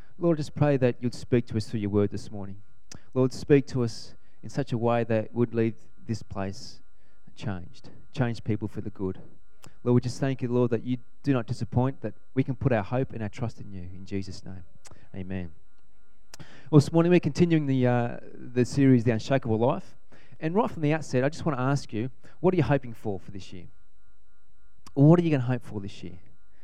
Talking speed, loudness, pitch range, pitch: 225 wpm, -27 LUFS, 105-135 Hz, 120 Hz